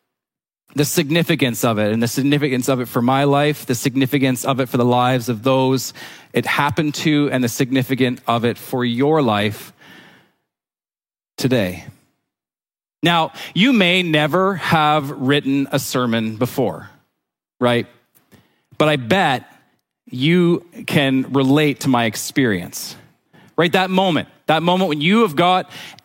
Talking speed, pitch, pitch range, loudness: 140 wpm, 140 Hz, 125-155 Hz, -18 LUFS